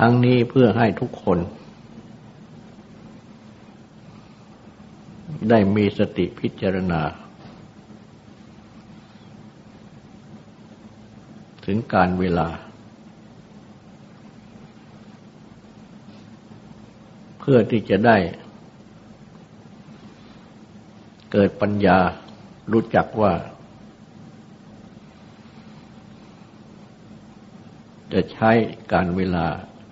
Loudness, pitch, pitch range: -20 LUFS, 105 Hz, 90-115 Hz